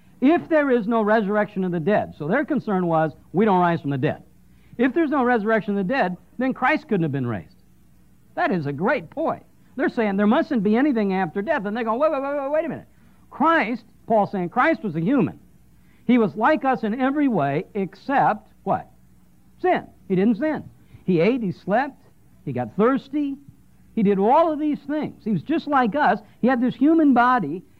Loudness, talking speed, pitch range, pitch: -22 LUFS, 210 wpm, 195-280 Hz, 230 Hz